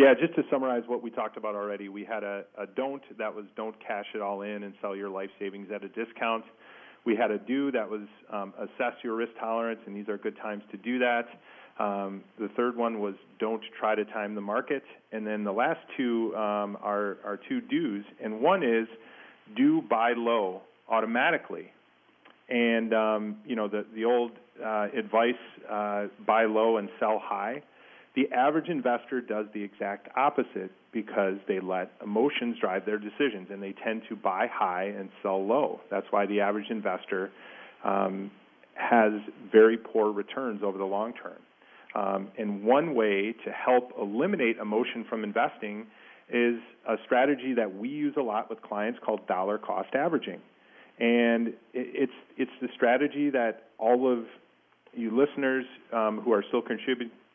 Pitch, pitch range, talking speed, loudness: 110 Hz, 105-120 Hz, 175 wpm, -29 LUFS